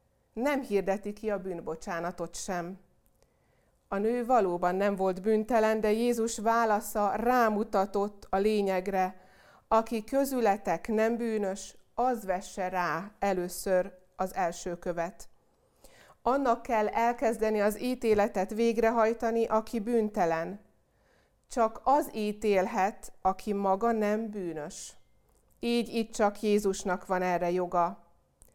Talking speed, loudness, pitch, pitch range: 105 wpm, -30 LUFS, 205 Hz, 185-225 Hz